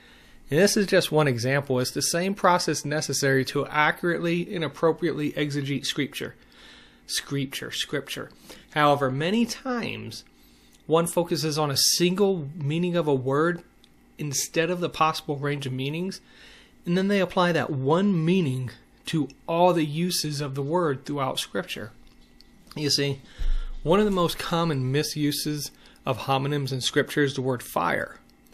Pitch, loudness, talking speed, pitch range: 150 Hz, -25 LUFS, 145 wpm, 135-170 Hz